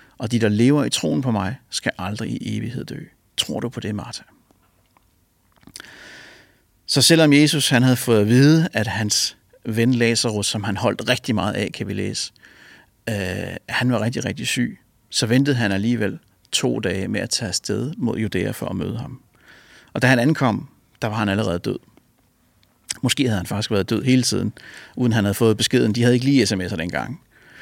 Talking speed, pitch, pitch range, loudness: 195 wpm, 115 Hz, 105-125 Hz, -20 LUFS